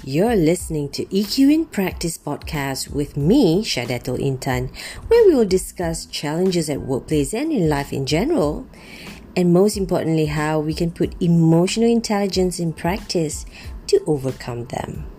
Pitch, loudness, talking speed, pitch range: 165 Hz, -20 LUFS, 145 wpm, 145-195 Hz